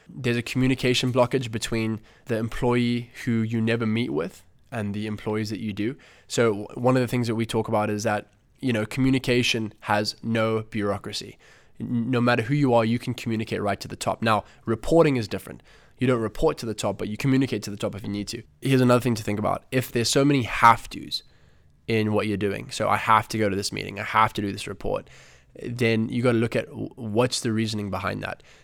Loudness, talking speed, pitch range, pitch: -25 LUFS, 225 wpm, 105-125 Hz, 115 Hz